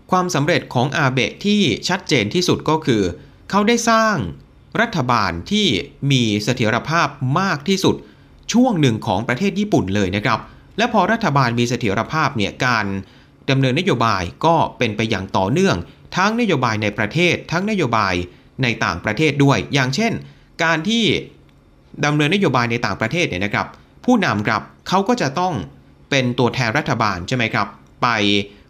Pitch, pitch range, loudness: 135 Hz, 110-180 Hz, -18 LUFS